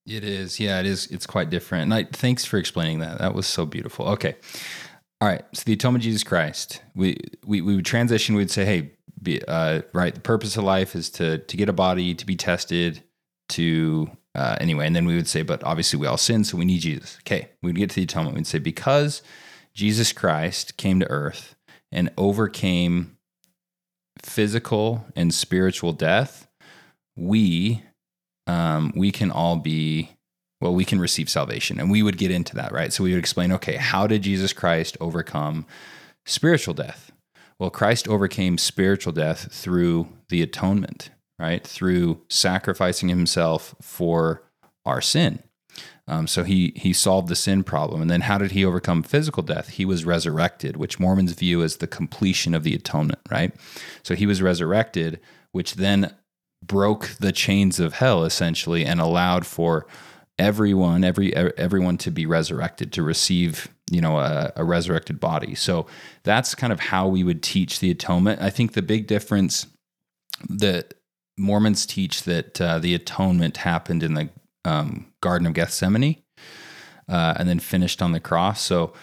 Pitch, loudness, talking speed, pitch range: 90 Hz, -22 LUFS, 175 wpm, 85-105 Hz